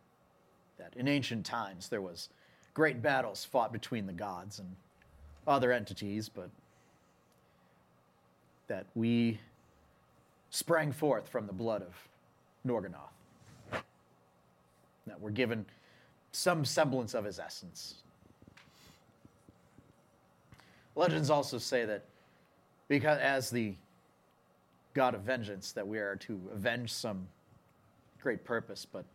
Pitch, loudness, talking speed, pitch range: 110 Hz, -35 LUFS, 105 wpm, 95-130 Hz